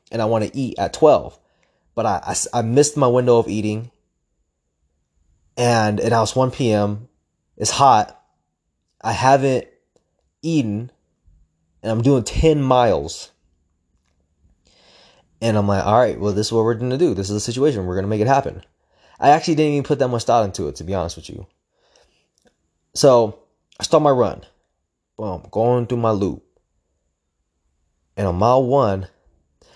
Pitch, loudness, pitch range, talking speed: 105 Hz, -18 LUFS, 80-125 Hz, 170 wpm